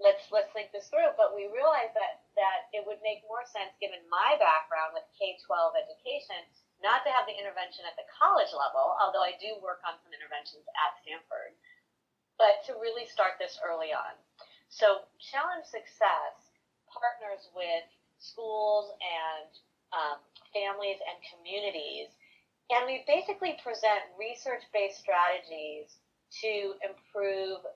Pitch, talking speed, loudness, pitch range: 210 Hz, 145 wpm, -31 LUFS, 185-275 Hz